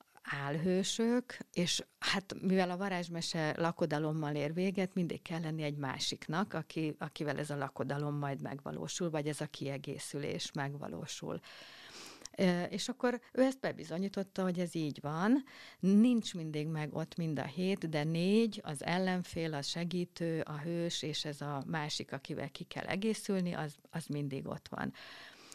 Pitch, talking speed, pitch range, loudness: 165 Hz, 150 wpm, 150-195 Hz, -36 LUFS